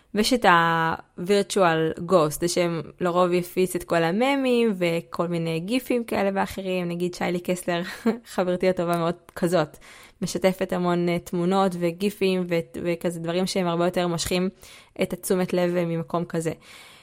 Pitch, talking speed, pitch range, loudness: 180 Hz, 140 wpm, 170-190 Hz, -24 LUFS